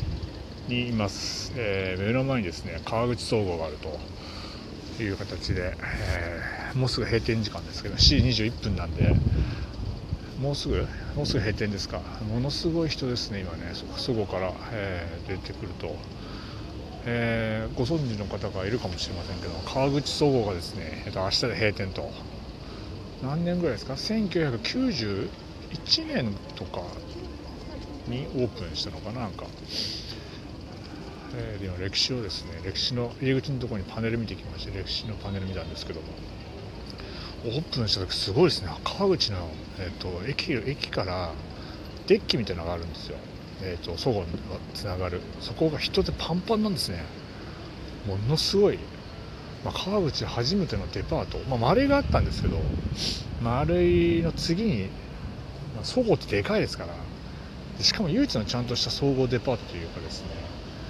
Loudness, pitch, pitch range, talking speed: -28 LUFS, 105 Hz, 90-120 Hz, 310 characters per minute